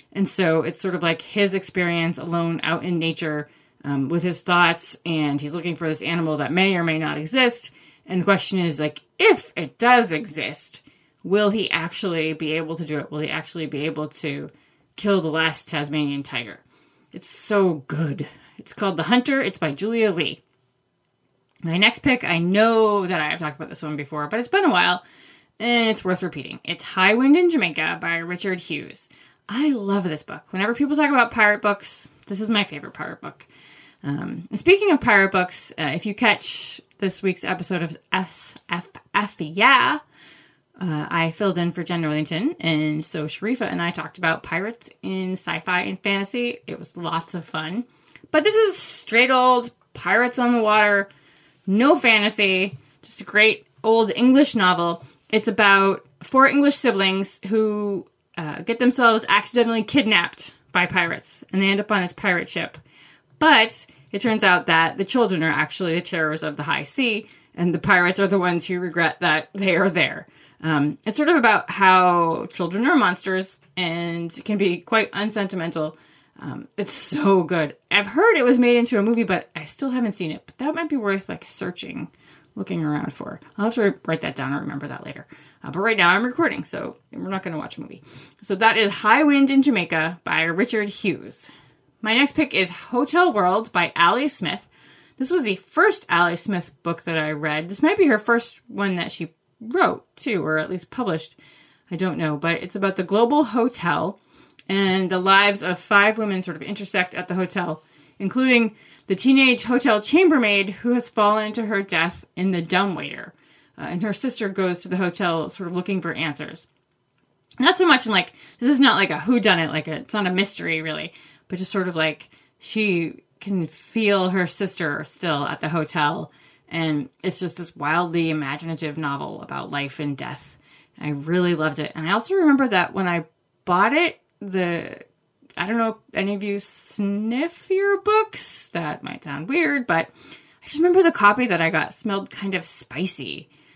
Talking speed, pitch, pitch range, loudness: 190 wpm, 185 Hz, 165-220 Hz, -21 LUFS